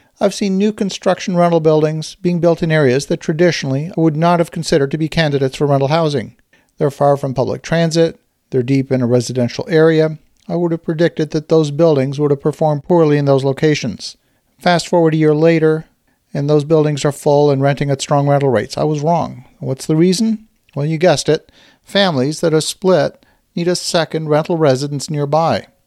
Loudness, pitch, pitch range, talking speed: -15 LUFS, 155 Hz, 145-170 Hz, 195 wpm